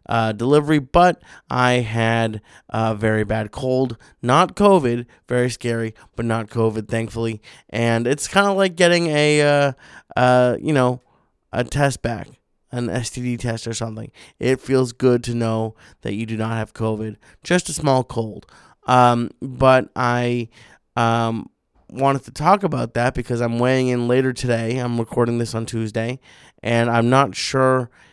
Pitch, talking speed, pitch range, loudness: 120 Hz, 160 wpm, 115-130 Hz, -20 LUFS